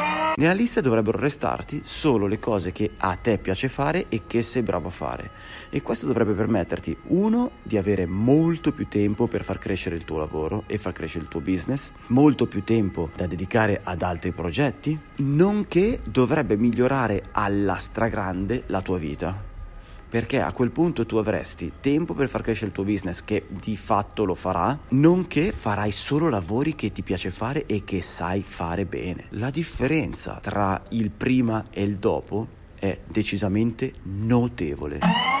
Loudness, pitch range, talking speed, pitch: -24 LUFS, 95-130 Hz, 165 wpm, 105 Hz